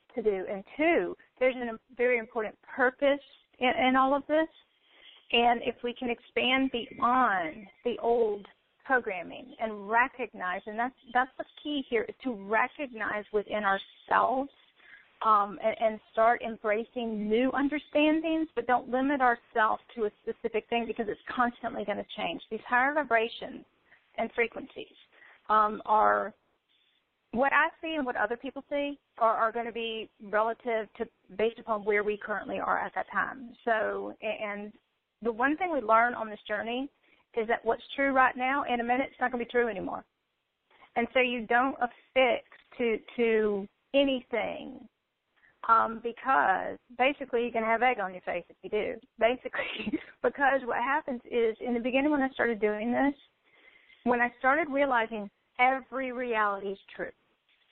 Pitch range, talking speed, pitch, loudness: 220-265 Hz, 165 wpm, 240 Hz, -29 LUFS